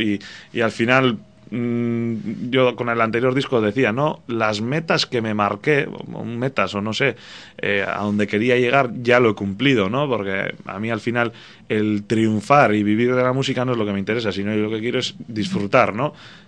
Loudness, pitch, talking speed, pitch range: -20 LUFS, 115 Hz, 210 wpm, 105-130 Hz